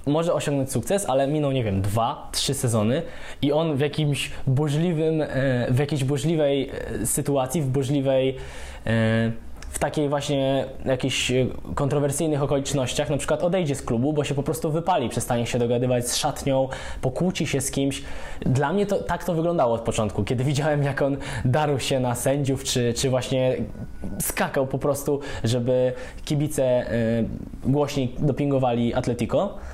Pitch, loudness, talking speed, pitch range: 135 Hz, -24 LUFS, 145 wpm, 125-145 Hz